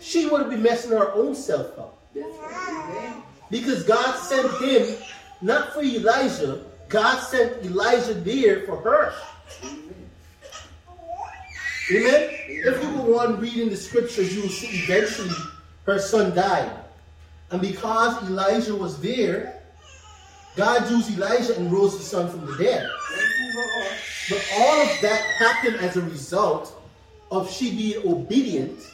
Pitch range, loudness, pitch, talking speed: 190-255 Hz, -22 LUFS, 225 Hz, 130 wpm